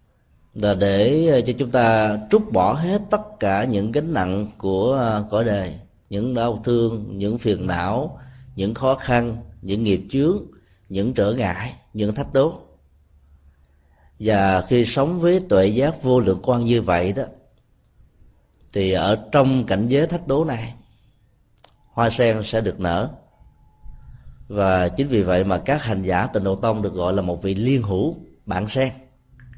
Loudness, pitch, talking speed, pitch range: -21 LUFS, 110 Hz, 160 wpm, 95-125 Hz